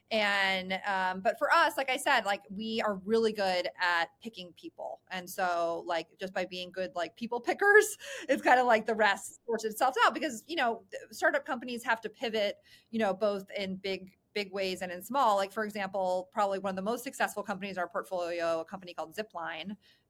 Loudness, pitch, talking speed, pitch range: -31 LUFS, 205 Hz, 210 wpm, 185-240 Hz